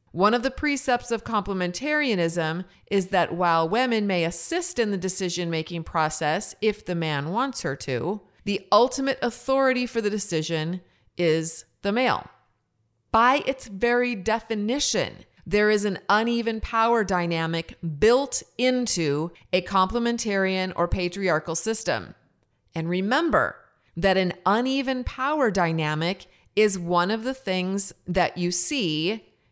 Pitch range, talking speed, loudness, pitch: 175-235 Hz, 130 wpm, -24 LUFS, 195 Hz